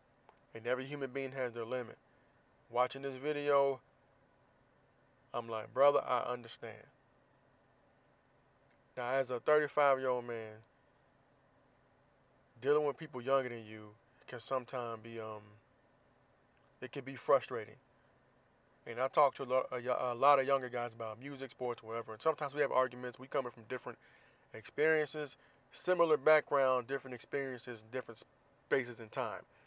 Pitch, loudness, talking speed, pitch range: 130 Hz, -36 LUFS, 140 wpm, 120-140 Hz